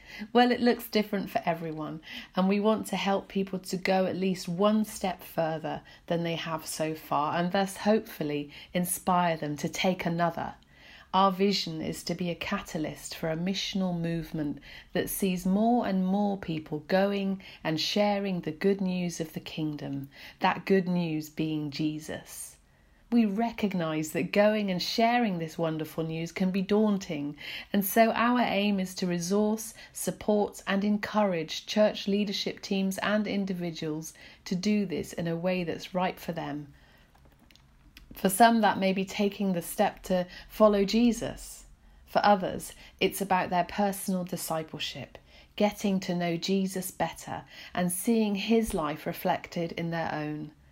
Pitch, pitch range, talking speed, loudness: 185 Hz, 165-205 Hz, 155 wpm, -29 LUFS